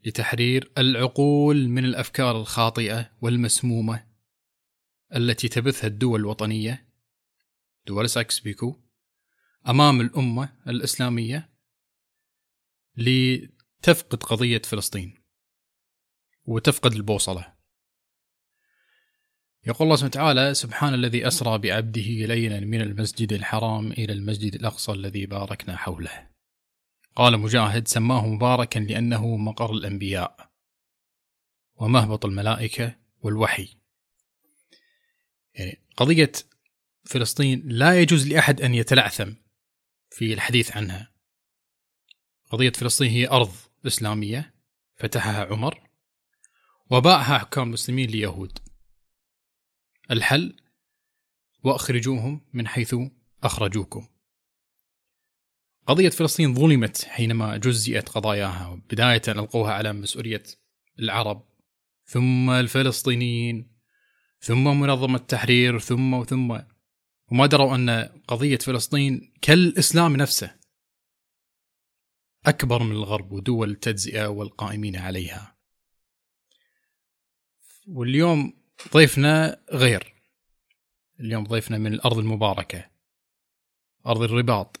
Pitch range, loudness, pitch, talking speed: 110-130 Hz, -22 LUFS, 120 Hz, 85 wpm